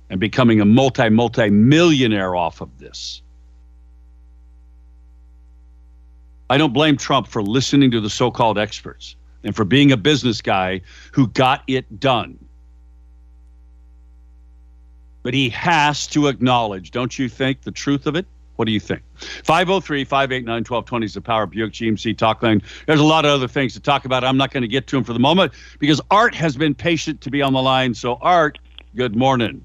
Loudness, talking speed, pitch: -18 LUFS, 180 wpm, 115 Hz